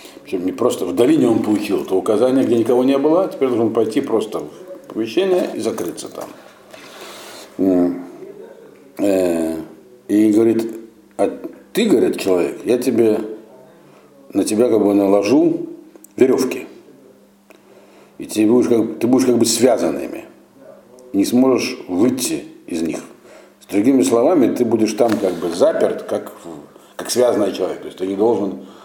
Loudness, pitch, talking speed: -17 LUFS, 125 Hz, 140 wpm